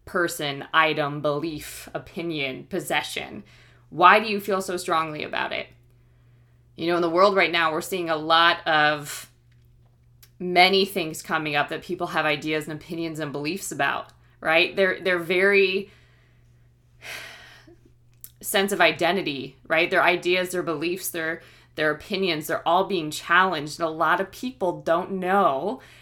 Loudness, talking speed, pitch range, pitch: -23 LUFS, 150 wpm, 140-180 Hz, 160 Hz